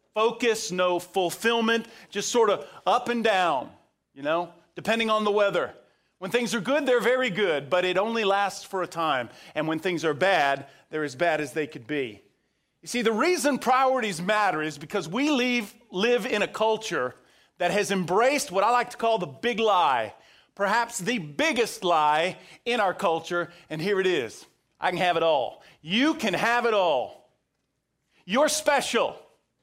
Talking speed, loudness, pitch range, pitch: 180 wpm, -25 LUFS, 175-235 Hz, 205 Hz